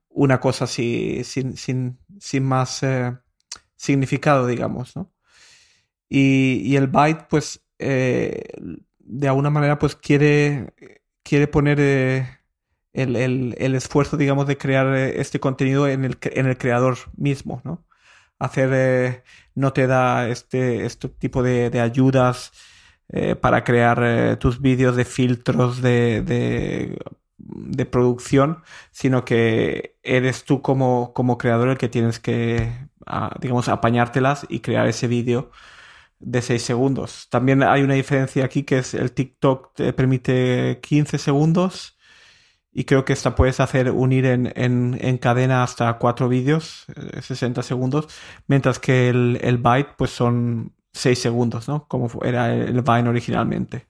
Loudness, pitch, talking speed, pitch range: -20 LUFS, 130 Hz, 145 wpm, 125-140 Hz